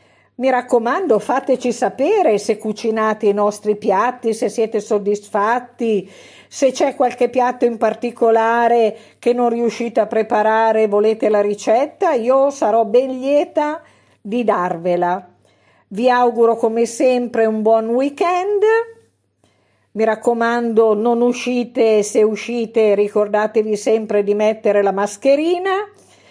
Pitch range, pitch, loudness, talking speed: 215-250 Hz, 230 Hz, -17 LUFS, 120 wpm